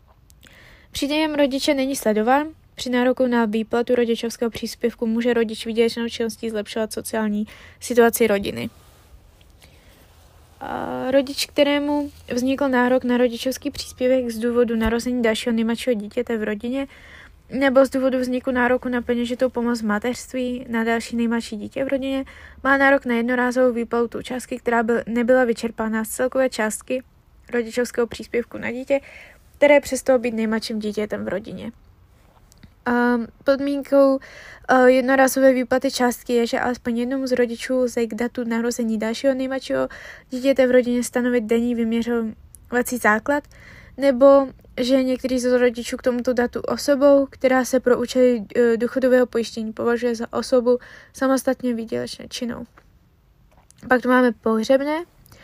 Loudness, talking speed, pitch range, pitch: -21 LUFS, 135 wpm, 230-260 Hz, 245 Hz